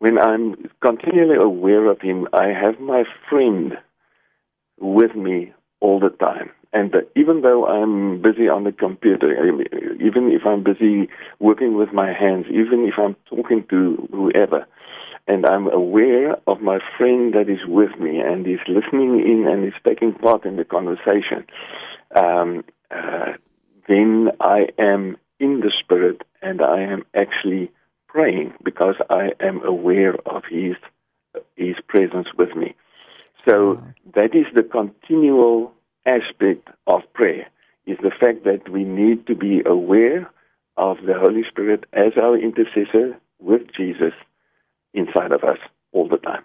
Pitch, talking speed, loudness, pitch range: 110 Hz, 145 wpm, -18 LUFS, 100-120 Hz